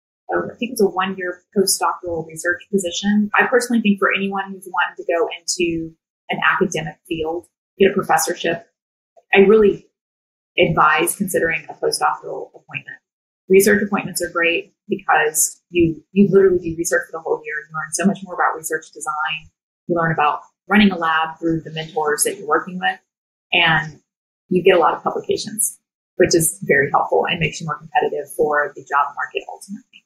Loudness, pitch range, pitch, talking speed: -18 LUFS, 160-200 Hz, 180 Hz, 175 wpm